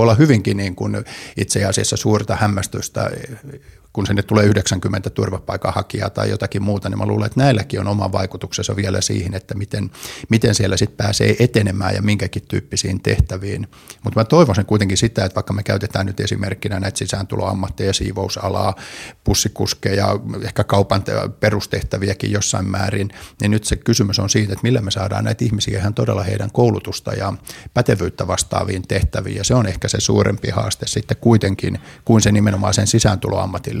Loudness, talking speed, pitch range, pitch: -18 LUFS, 160 wpm, 95-110 Hz, 100 Hz